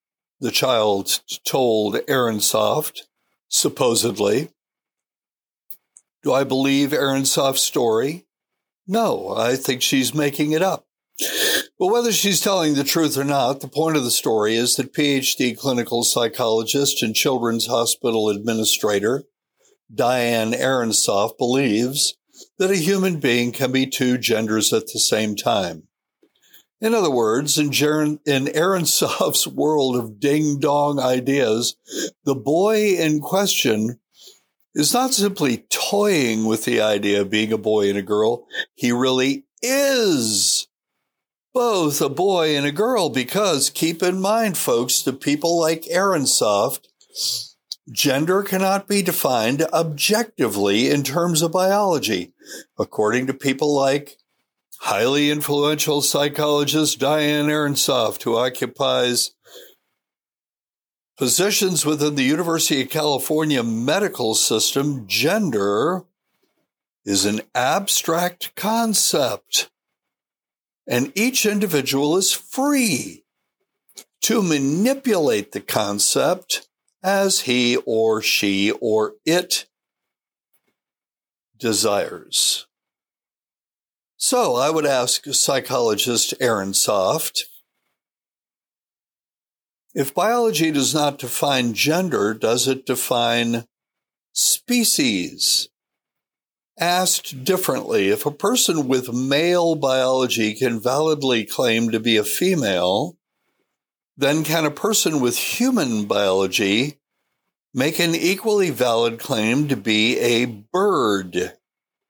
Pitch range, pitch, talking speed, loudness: 120-175 Hz, 145 Hz, 105 wpm, -19 LUFS